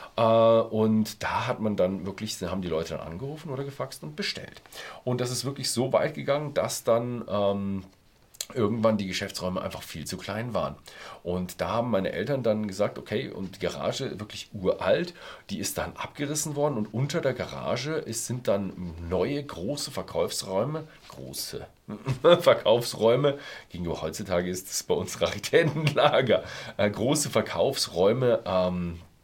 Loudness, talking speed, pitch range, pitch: -27 LUFS, 155 wpm, 95-135 Hz, 110 Hz